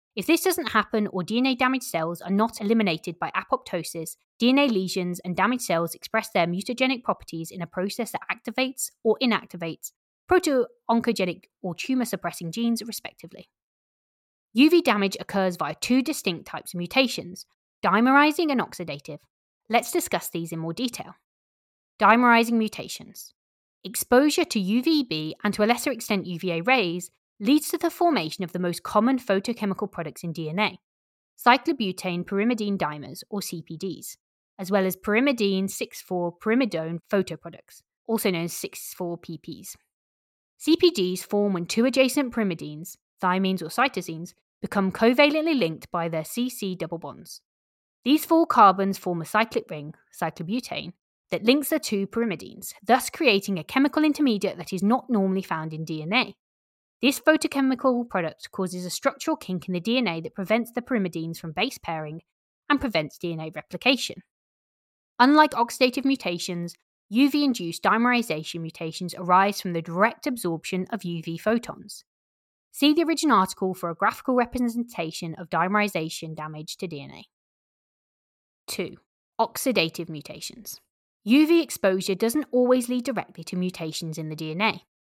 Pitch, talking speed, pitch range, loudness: 200 Hz, 140 wpm, 175-250 Hz, -24 LUFS